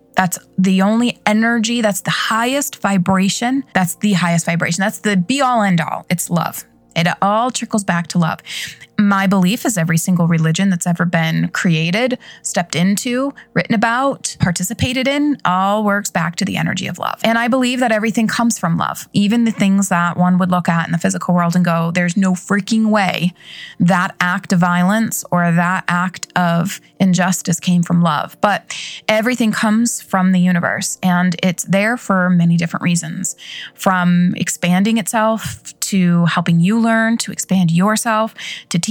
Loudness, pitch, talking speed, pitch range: -16 LUFS, 190 Hz, 175 wpm, 175-220 Hz